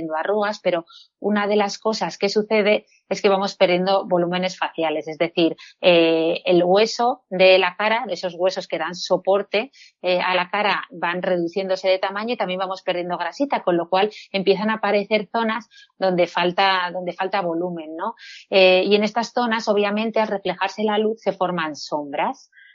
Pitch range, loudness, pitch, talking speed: 180-210 Hz, -21 LUFS, 190 Hz, 175 wpm